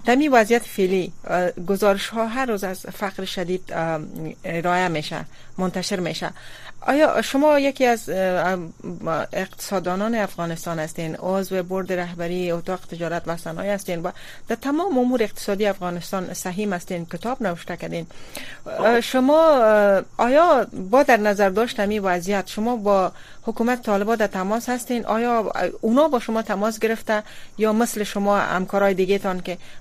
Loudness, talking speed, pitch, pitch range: -22 LUFS, 130 wpm, 200 Hz, 180-225 Hz